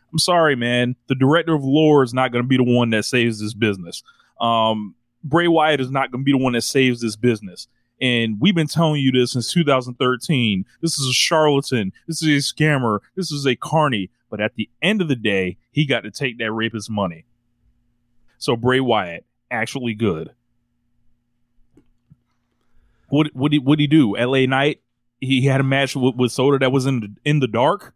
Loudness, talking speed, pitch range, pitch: -19 LUFS, 195 wpm, 120-145 Hz, 125 Hz